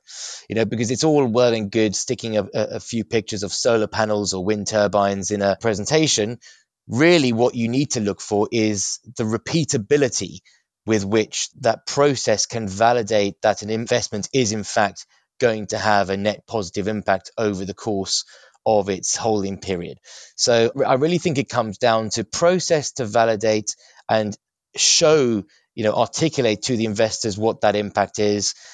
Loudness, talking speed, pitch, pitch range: -20 LUFS, 170 wpm, 110 Hz, 105-120 Hz